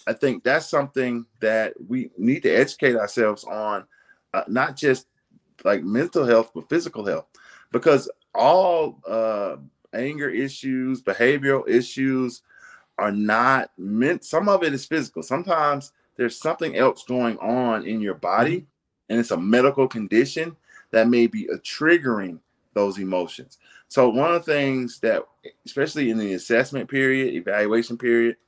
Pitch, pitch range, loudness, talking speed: 130 Hz, 115-155 Hz, -22 LUFS, 145 wpm